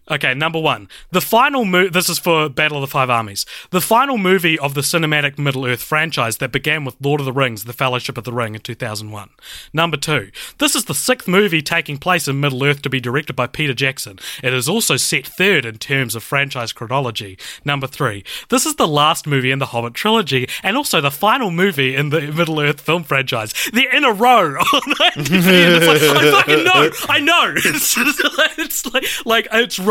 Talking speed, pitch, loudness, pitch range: 215 wpm, 150 Hz, -15 LUFS, 130-195 Hz